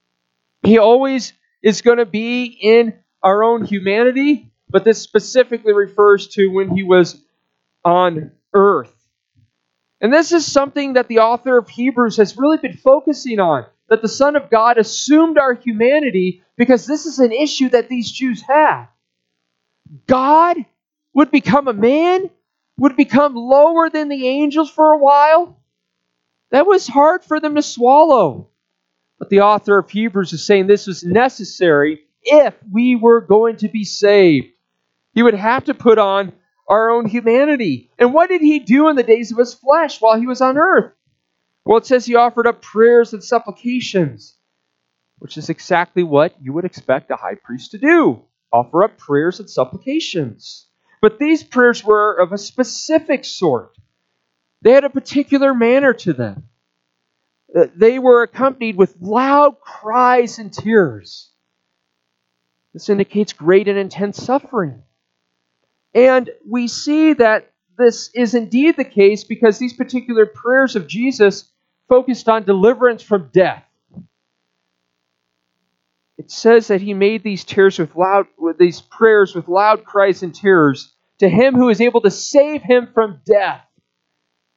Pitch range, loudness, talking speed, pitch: 175-255 Hz, -14 LUFS, 155 wpm, 220 Hz